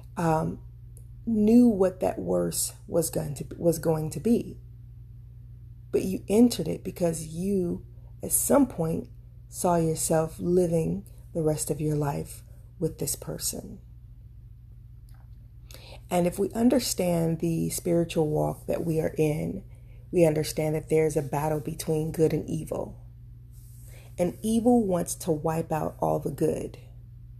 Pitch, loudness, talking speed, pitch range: 155 Hz, -27 LUFS, 135 wpm, 120-170 Hz